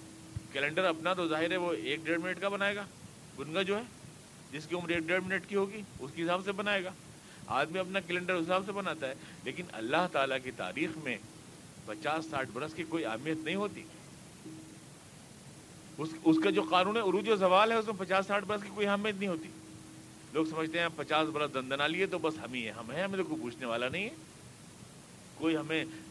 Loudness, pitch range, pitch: -33 LUFS, 150-190 Hz, 170 Hz